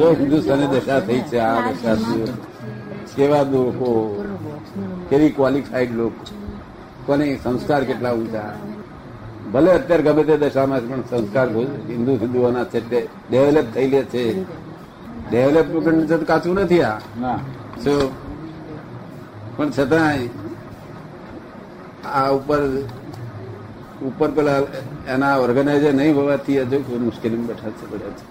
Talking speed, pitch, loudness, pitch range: 110 wpm, 135 Hz, -19 LUFS, 120-145 Hz